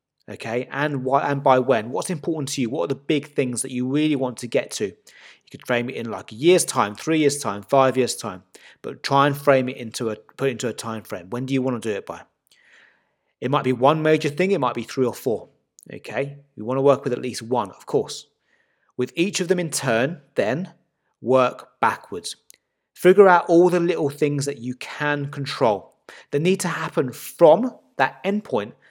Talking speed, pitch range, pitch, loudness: 220 wpm, 125-150 Hz, 135 Hz, -22 LUFS